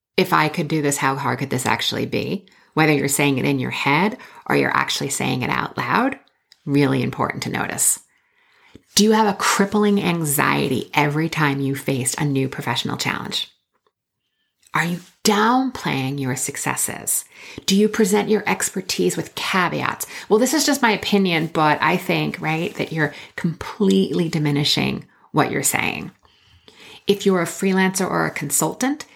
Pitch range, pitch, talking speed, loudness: 145-205 Hz, 165 Hz, 165 wpm, -20 LUFS